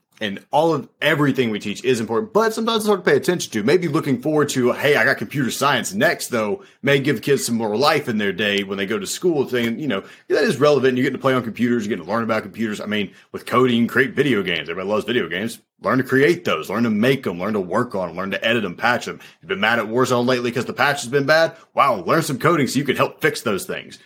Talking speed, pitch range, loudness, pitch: 280 wpm, 115-145 Hz, -20 LUFS, 130 Hz